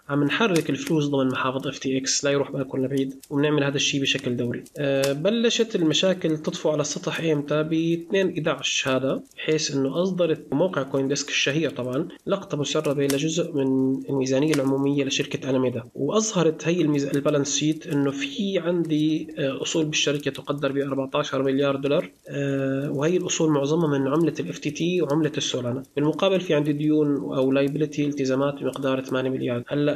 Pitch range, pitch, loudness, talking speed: 135-155 Hz, 145 Hz, -24 LUFS, 160 wpm